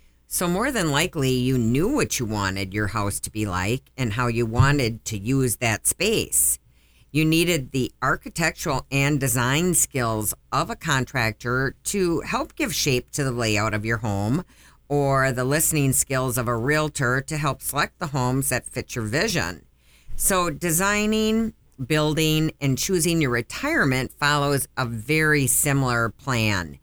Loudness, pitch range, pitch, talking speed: -22 LUFS, 115-150 Hz, 130 Hz, 155 wpm